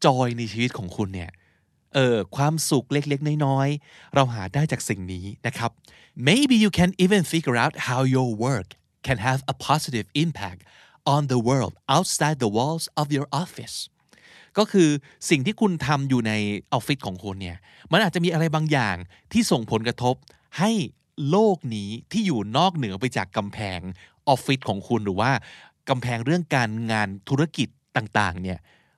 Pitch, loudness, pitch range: 130 Hz, -24 LUFS, 110-155 Hz